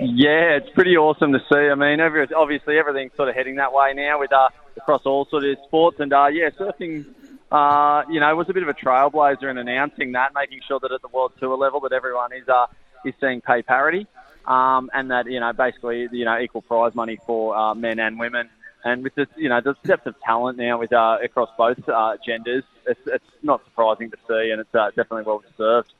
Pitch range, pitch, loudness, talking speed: 120-145 Hz, 135 Hz, -20 LUFS, 230 wpm